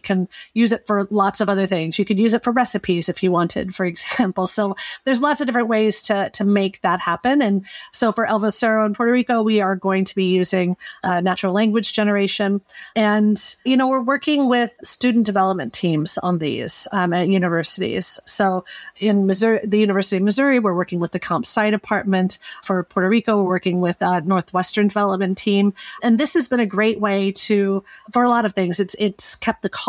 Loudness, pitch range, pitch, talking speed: -19 LUFS, 190-225 Hz, 200 Hz, 205 wpm